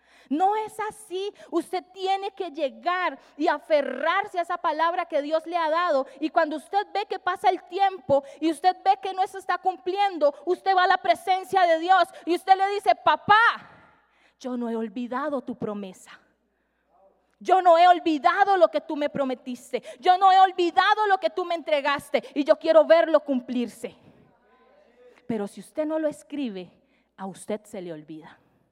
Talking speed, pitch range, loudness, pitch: 180 wpm, 280-375 Hz, -24 LUFS, 330 Hz